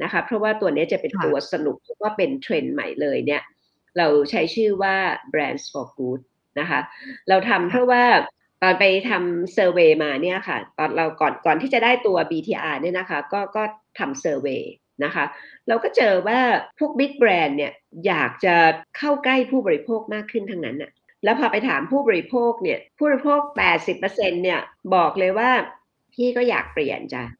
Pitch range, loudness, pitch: 170-245 Hz, -21 LUFS, 200 Hz